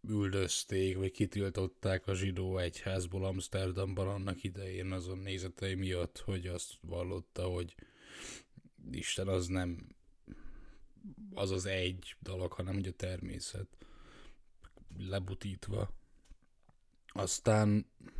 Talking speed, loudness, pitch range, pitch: 95 wpm, -38 LUFS, 90-100 Hz, 95 Hz